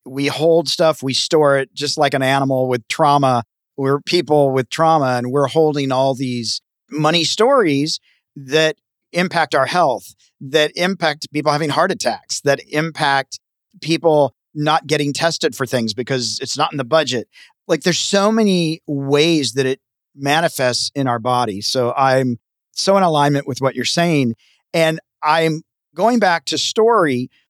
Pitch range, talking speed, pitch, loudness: 130-160 Hz, 160 wpm, 145 Hz, -17 LUFS